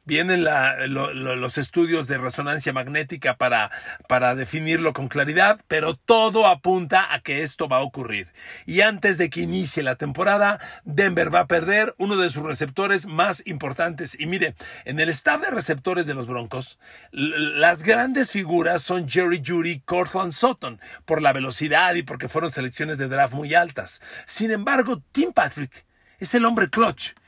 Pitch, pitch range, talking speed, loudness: 170 Hz, 145-195 Hz, 170 wpm, -21 LUFS